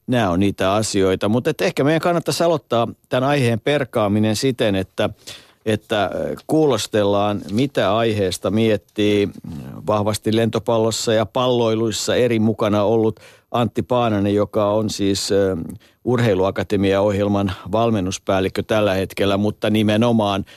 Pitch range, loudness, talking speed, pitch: 100-115 Hz, -19 LUFS, 115 wpm, 110 Hz